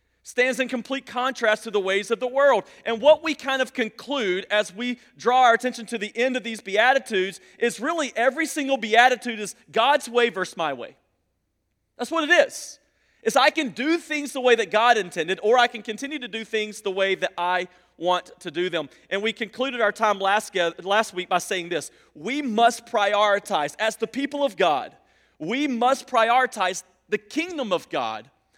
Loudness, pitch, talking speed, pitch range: -23 LUFS, 230 Hz, 195 wpm, 200-260 Hz